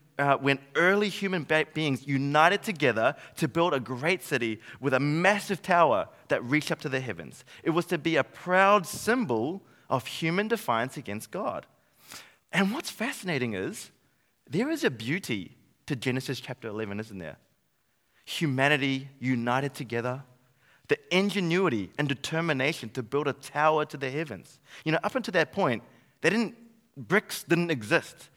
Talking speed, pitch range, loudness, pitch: 155 wpm, 130-180 Hz, -28 LUFS, 150 Hz